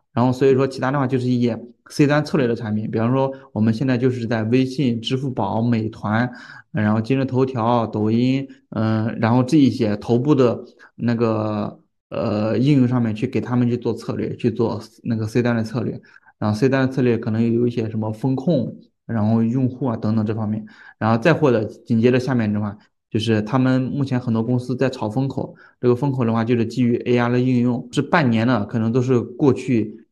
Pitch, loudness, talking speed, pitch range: 120 Hz, -20 LUFS, 310 characters per minute, 110-130 Hz